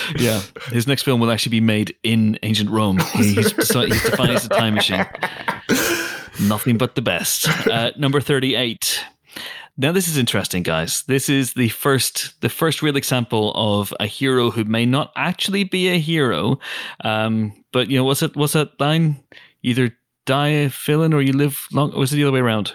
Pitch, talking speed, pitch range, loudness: 130 Hz, 195 wpm, 110-145 Hz, -19 LUFS